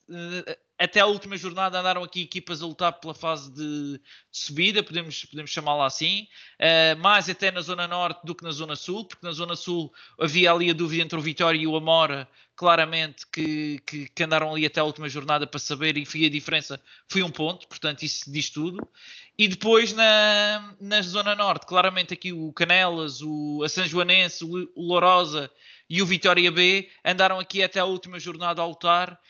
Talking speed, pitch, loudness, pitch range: 185 wpm, 170 Hz, -23 LUFS, 155-185 Hz